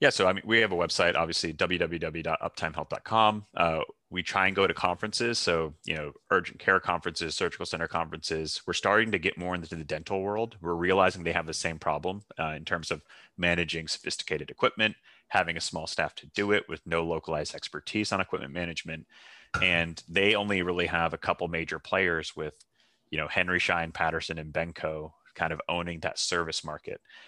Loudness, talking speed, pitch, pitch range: -29 LUFS, 190 wpm, 85 Hz, 80-95 Hz